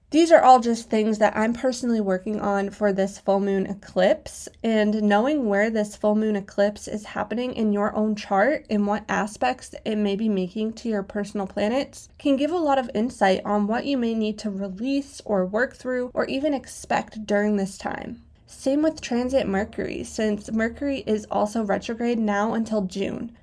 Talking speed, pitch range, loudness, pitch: 185 wpm, 205-250 Hz, -24 LUFS, 215 Hz